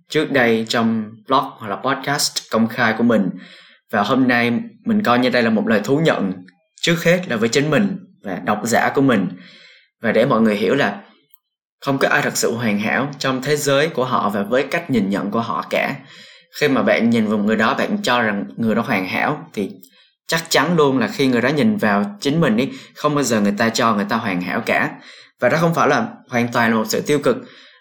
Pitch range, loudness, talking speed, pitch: 115-165 Hz, -18 LUFS, 235 wpm, 135 Hz